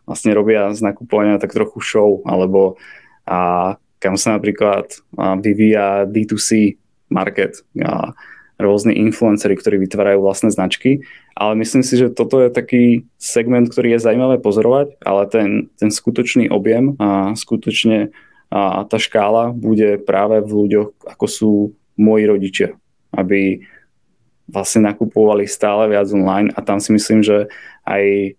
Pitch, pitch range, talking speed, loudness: 105 Hz, 100-110 Hz, 140 wpm, -15 LUFS